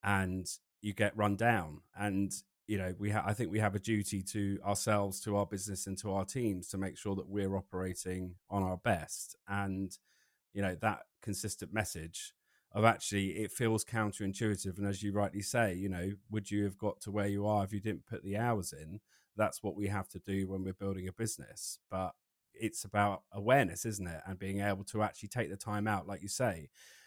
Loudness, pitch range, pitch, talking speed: -36 LUFS, 95-105 Hz, 100 Hz, 215 wpm